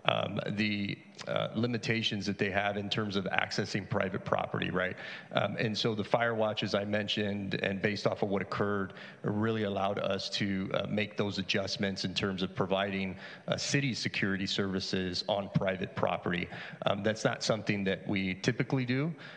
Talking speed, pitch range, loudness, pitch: 170 wpm, 95-110 Hz, -32 LUFS, 100 Hz